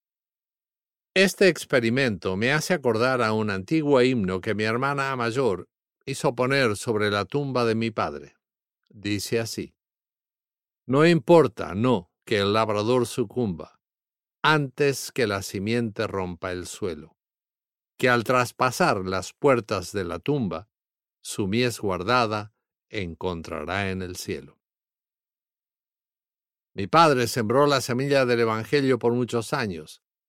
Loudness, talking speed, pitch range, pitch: -24 LUFS, 125 wpm, 105-130 Hz, 120 Hz